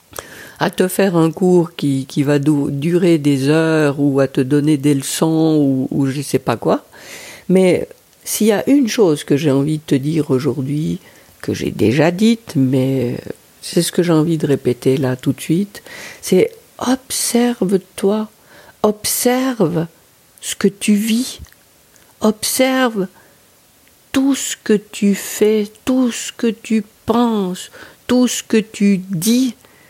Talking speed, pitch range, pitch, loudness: 155 wpm, 145-220 Hz, 180 Hz, -16 LUFS